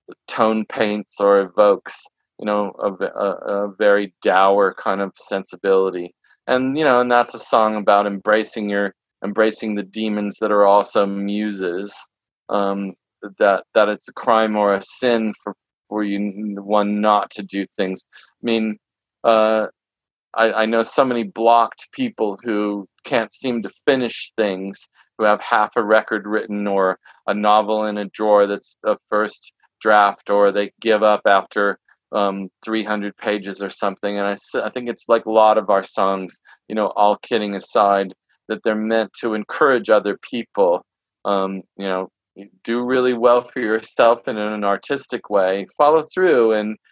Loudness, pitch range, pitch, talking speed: -19 LUFS, 100-110 Hz, 105 Hz, 165 wpm